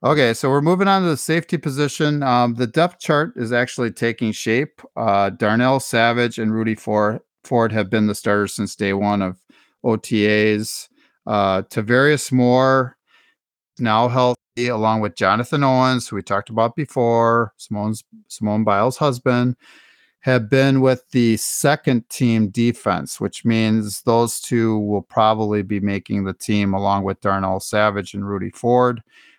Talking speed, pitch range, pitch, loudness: 150 wpm, 105-130 Hz, 115 Hz, -19 LUFS